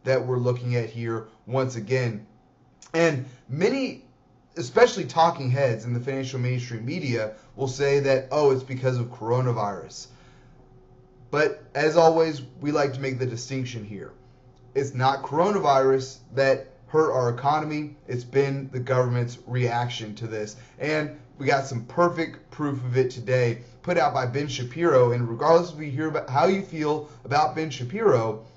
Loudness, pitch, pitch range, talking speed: -25 LUFS, 130 Hz, 125-145 Hz, 155 wpm